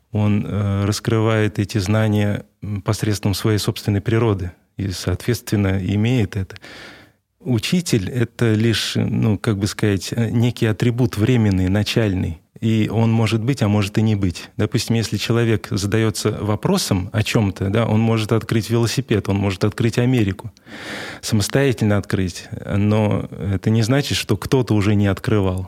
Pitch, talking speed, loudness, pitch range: 110 Hz, 140 wpm, -19 LUFS, 100-115 Hz